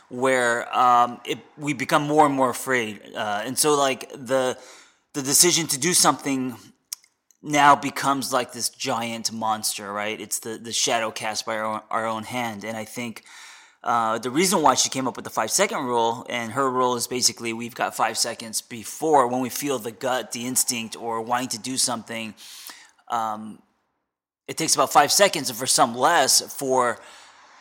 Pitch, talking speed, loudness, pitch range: 125 Hz, 185 wpm, -22 LUFS, 115-135 Hz